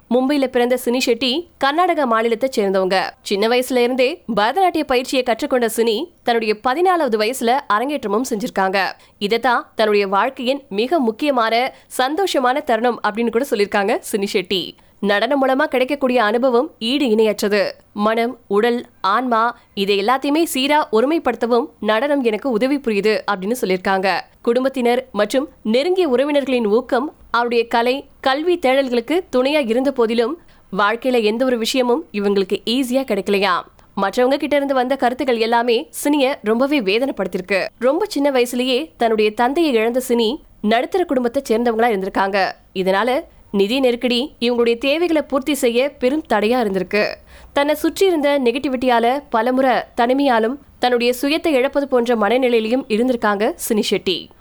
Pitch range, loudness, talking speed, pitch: 225-270 Hz, -18 LUFS, 125 wpm, 245 Hz